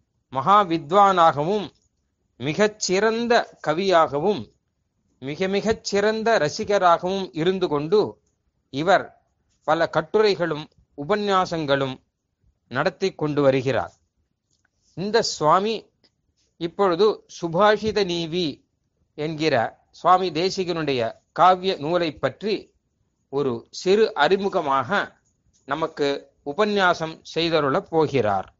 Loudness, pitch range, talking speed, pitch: -22 LUFS, 135-195 Hz, 75 wpm, 165 Hz